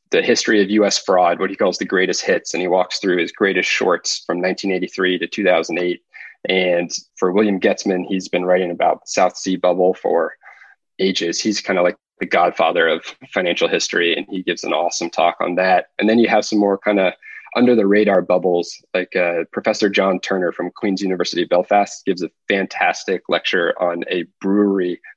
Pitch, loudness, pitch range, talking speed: 95 Hz, -18 LUFS, 90-100 Hz, 190 wpm